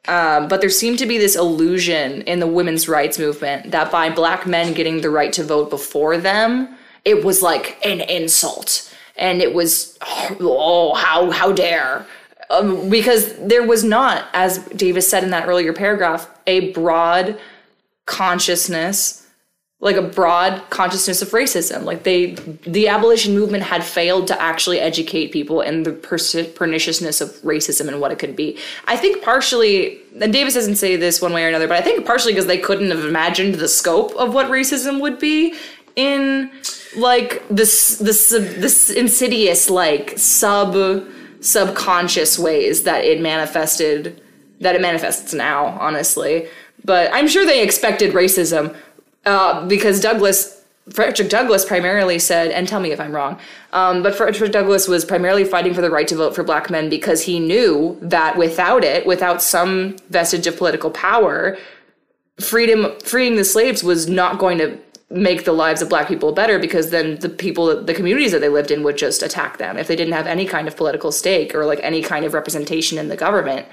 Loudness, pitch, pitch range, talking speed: -16 LUFS, 180 Hz, 165-210 Hz, 175 wpm